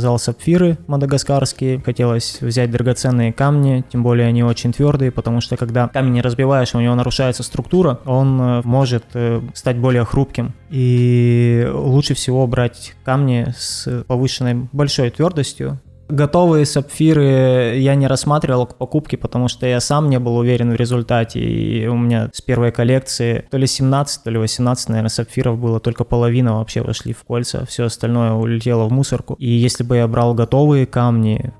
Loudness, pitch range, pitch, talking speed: -16 LUFS, 120-135 Hz, 125 Hz, 160 wpm